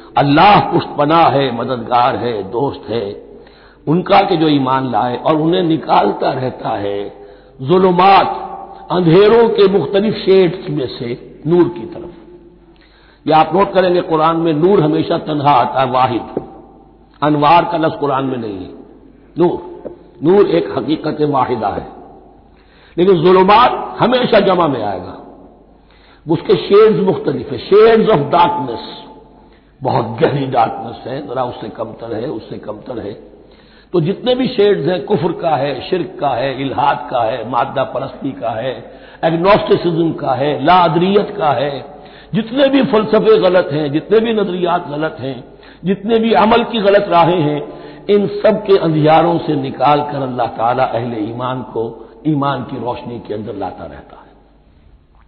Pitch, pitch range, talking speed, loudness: 165 Hz, 135-195 Hz, 150 wpm, -14 LUFS